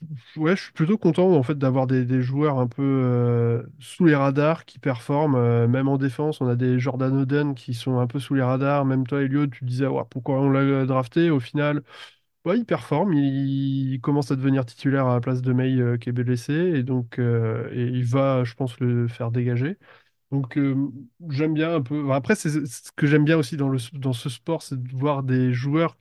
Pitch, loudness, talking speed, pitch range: 135 Hz, -23 LUFS, 235 wpm, 125-145 Hz